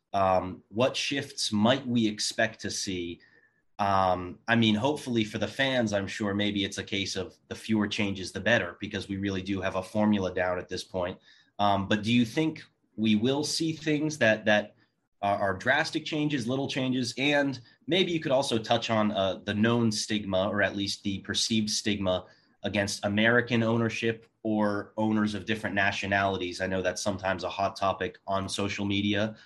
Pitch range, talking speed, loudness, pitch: 100-115 Hz, 185 wpm, -28 LUFS, 105 Hz